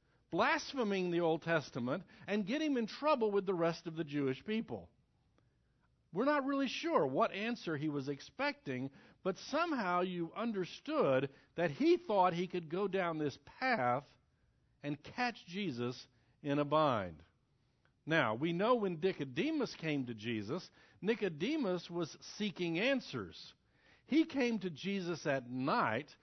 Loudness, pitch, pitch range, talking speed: -36 LUFS, 180 Hz, 145-225 Hz, 140 wpm